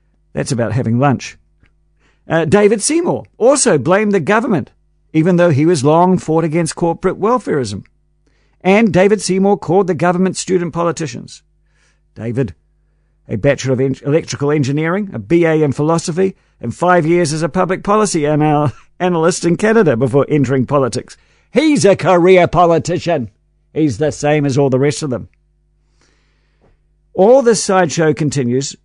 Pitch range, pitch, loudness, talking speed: 140-185 Hz, 165 Hz, -14 LUFS, 145 wpm